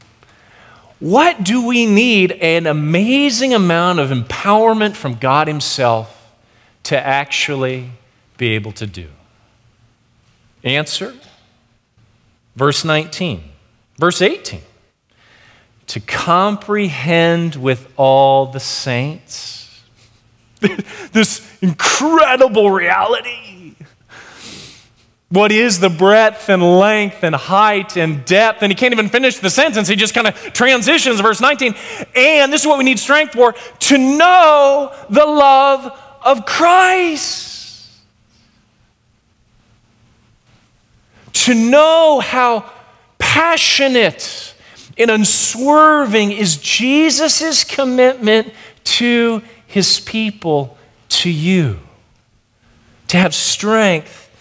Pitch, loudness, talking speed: 180 Hz, -12 LUFS, 95 wpm